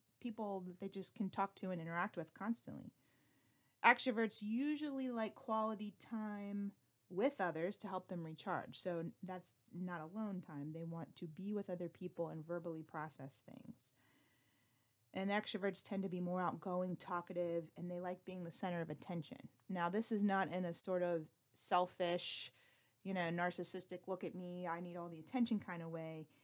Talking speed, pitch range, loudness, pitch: 175 wpm, 170-200 Hz, -43 LUFS, 180 Hz